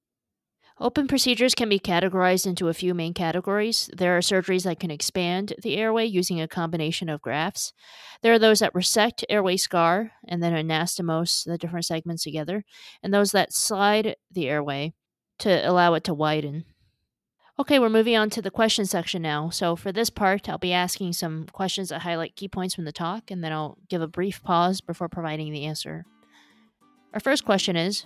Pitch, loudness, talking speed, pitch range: 180 Hz, -24 LUFS, 190 wpm, 165-205 Hz